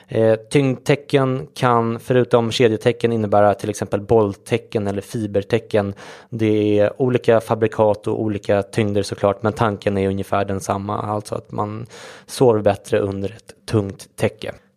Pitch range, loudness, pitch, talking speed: 100-115 Hz, -19 LUFS, 110 Hz, 135 wpm